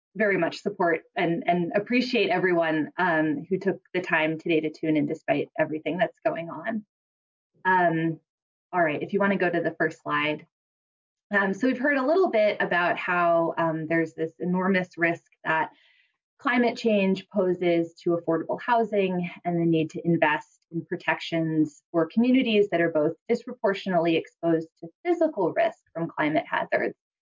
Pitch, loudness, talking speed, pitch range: 170 Hz, -25 LUFS, 165 wpm, 160-205 Hz